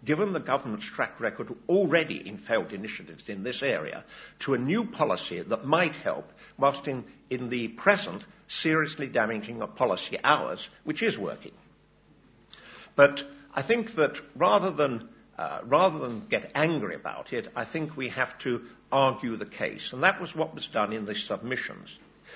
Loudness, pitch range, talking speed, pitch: -28 LUFS, 120-155 Hz, 165 wpm, 135 Hz